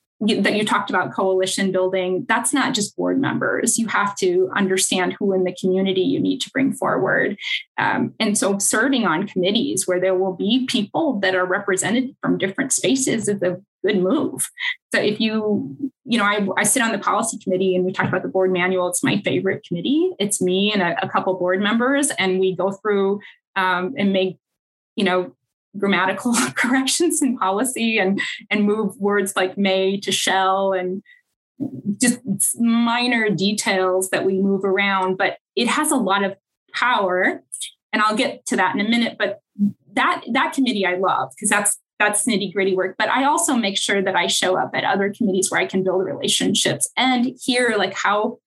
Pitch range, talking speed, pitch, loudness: 190-240 Hz, 190 wpm, 205 Hz, -20 LUFS